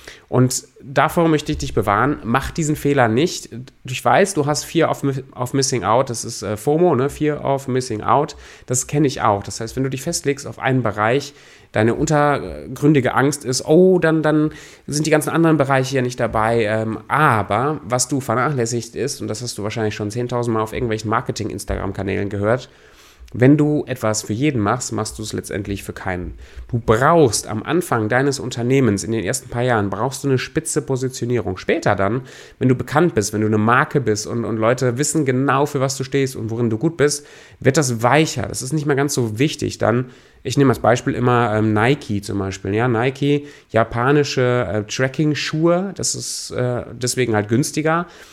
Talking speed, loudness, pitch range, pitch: 195 wpm, -19 LUFS, 110-145 Hz, 125 Hz